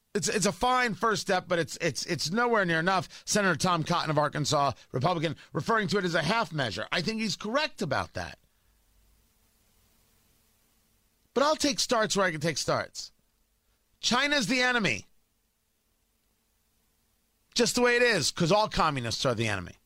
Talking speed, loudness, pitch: 165 wpm, -27 LUFS, 175 Hz